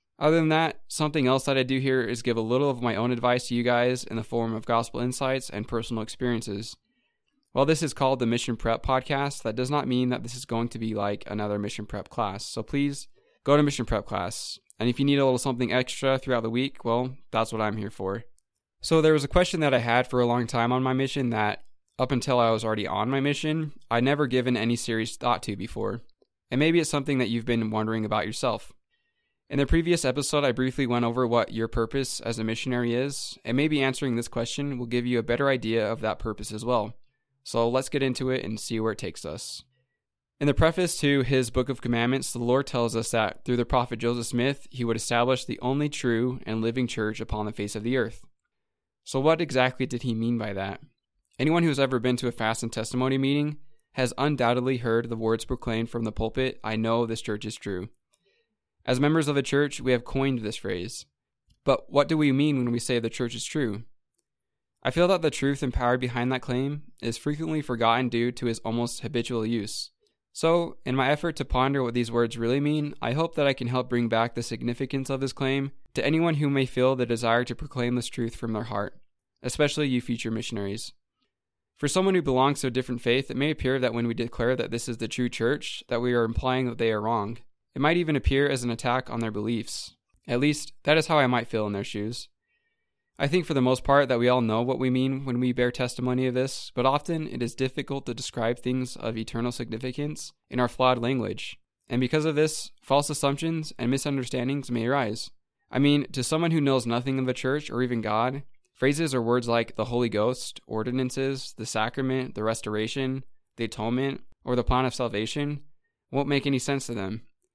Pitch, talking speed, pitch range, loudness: 125 Hz, 225 wpm, 115-140 Hz, -27 LUFS